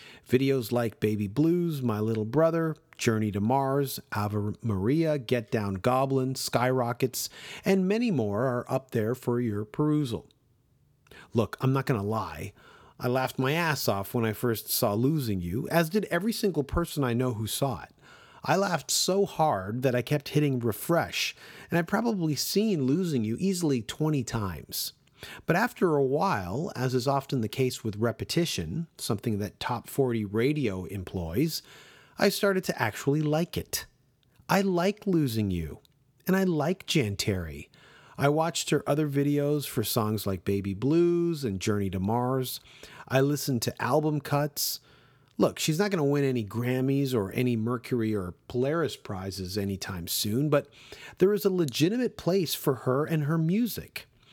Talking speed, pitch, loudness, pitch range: 160 wpm, 130 Hz, -28 LUFS, 115-155 Hz